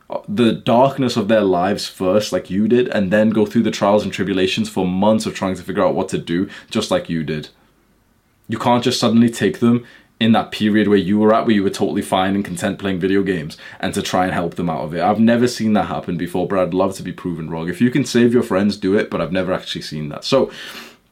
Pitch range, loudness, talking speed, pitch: 95-115 Hz, -18 LUFS, 260 wpm, 105 Hz